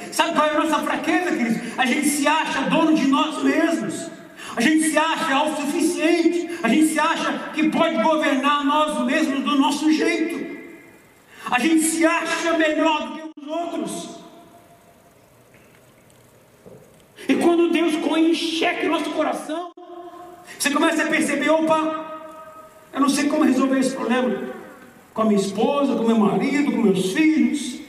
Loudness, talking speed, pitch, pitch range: -20 LUFS, 155 wpm, 310 Hz, 285-325 Hz